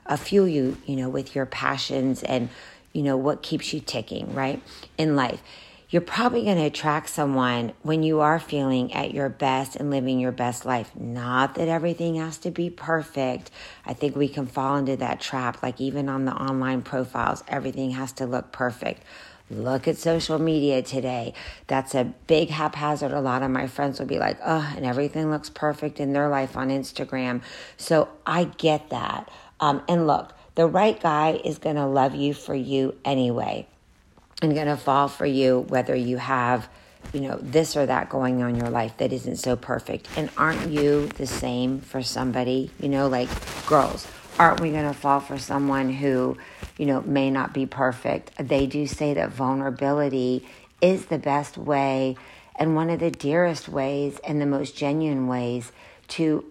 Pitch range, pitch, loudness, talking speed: 130-150 Hz, 140 Hz, -25 LUFS, 185 wpm